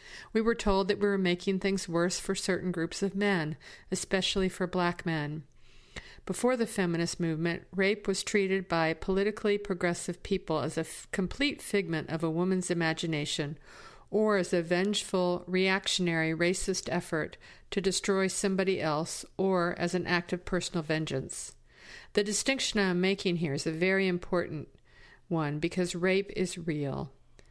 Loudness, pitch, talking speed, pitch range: -30 LUFS, 180 Hz, 155 wpm, 165-195 Hz